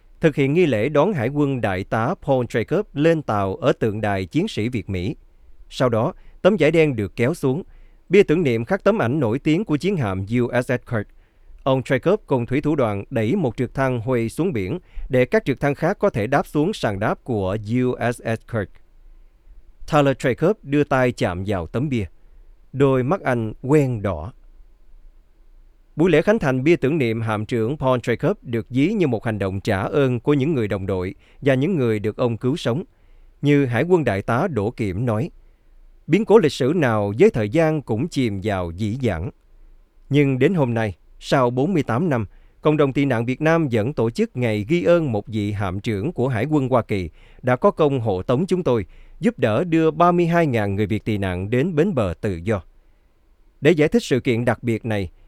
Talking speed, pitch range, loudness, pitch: 205 wpm, 105-145 Hz, -21 LUFS, 120 Hz